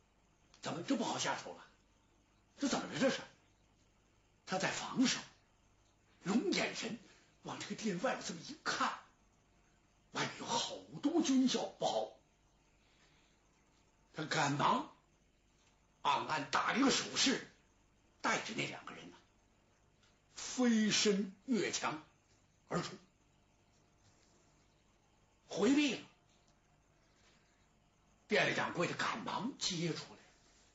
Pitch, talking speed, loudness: 195 Hz, 155 characters per minute, -36 LUFS